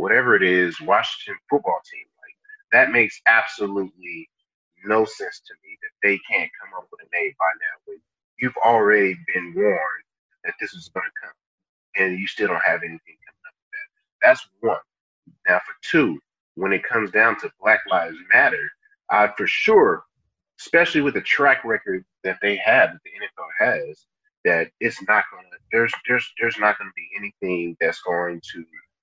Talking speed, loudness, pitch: 185 wpm, -20 LUFS, 395 Hz